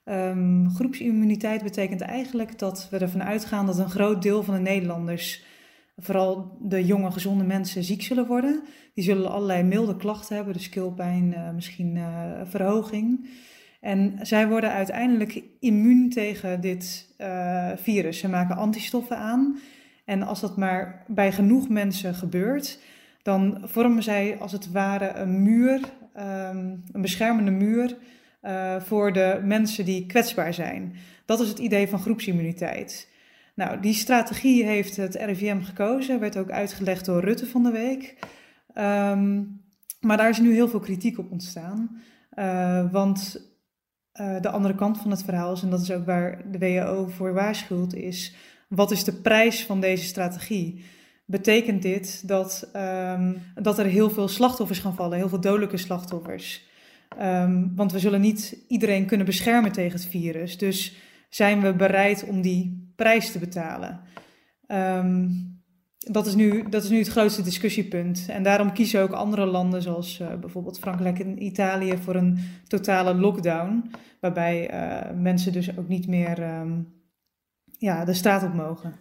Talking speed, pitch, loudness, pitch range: 155 wpm, 195 Hz, -25 LUFS, 185-215 Hz